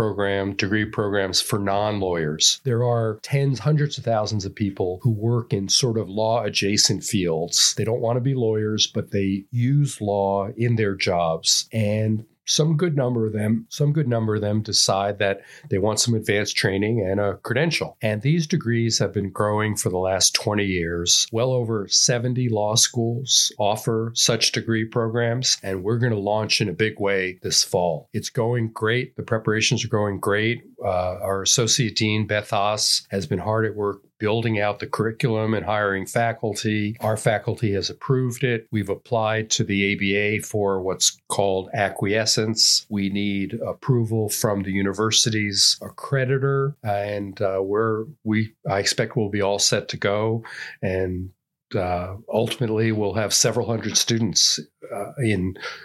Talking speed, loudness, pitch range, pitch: 165 wpm, -22 LUFS, 100-115 Hz, 110 Hz